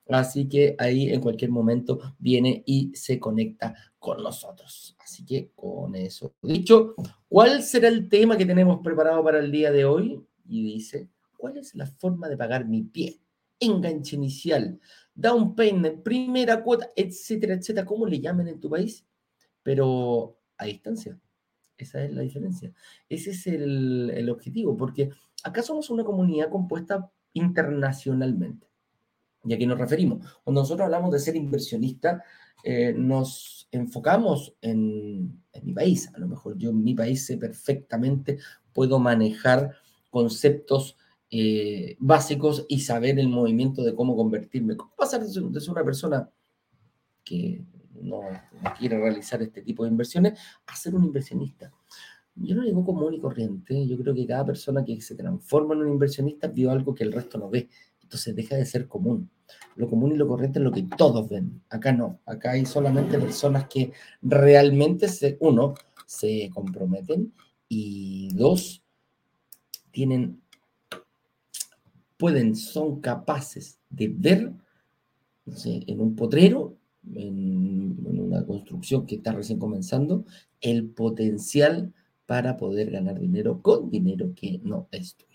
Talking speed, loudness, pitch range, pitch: 150 wpm, -25 LUFS, 120-185 Hz, 140 Hz